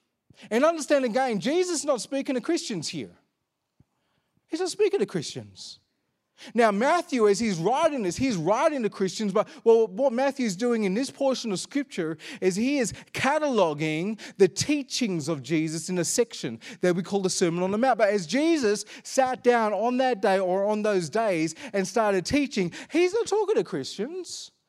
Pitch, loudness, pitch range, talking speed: 225 Hz, -25 LUFS, 190-275 Hz, 180 wpm